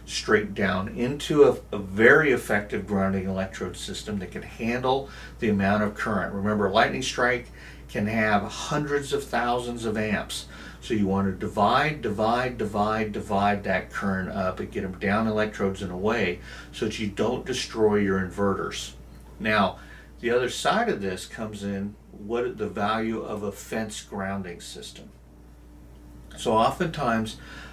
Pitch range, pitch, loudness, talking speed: 95-115 Hz, 105 Hz, -26 LUFS, 155 wpm